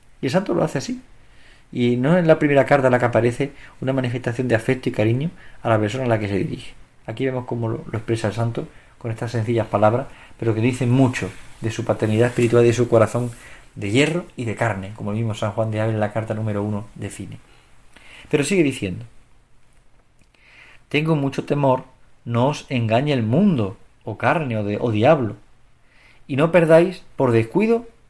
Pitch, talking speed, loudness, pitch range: 120 Hz, 200 wpm, -20 LUFS, 110-130 Hz